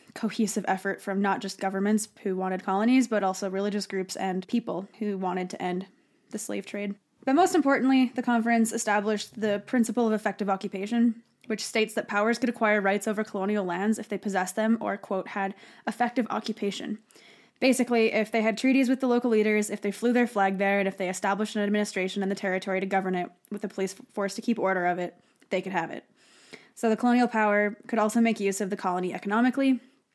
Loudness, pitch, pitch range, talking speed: -27 LUFS, 210 Hz, 195-230 Hz, 205 wpm